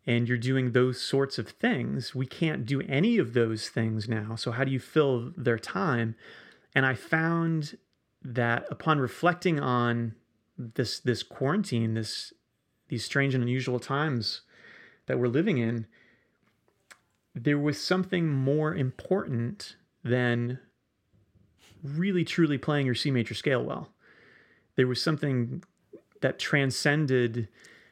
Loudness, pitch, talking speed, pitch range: -28 LUFS, 125 Hz, 130 wpm, 115-145 Hz